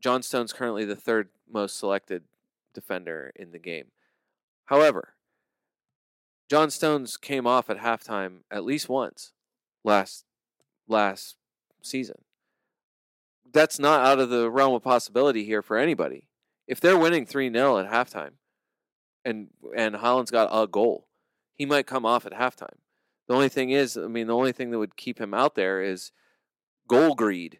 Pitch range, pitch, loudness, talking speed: 105-135 Hz, 120 Hz, -25 LUFS, 155 wpm